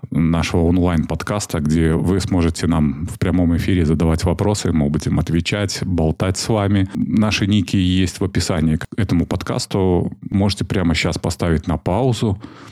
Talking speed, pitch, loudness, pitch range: 145 wpm, 90 Hz, -18 LUFS, 80-100 Hz